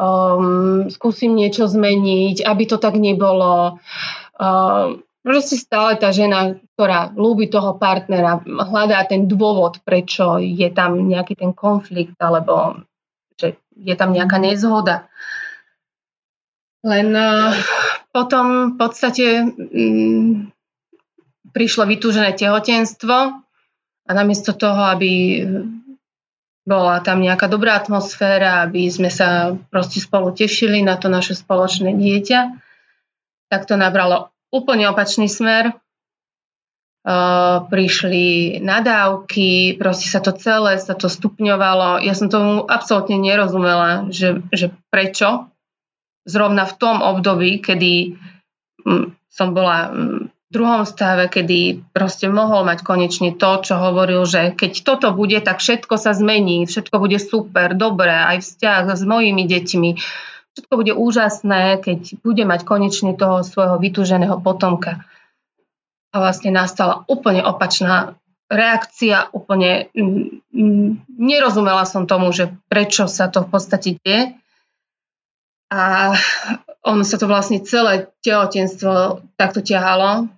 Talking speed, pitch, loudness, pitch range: 115 wpm, 195 Hz, -16 LUFS, 185-215 Hz